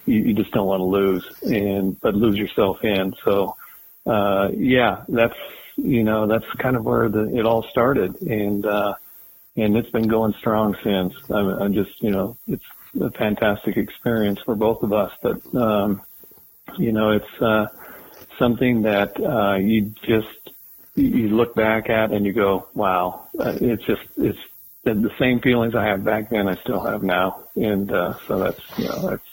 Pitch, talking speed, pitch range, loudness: 105 Hz, 175 wpm, 100-115 Hz, -21 LUFS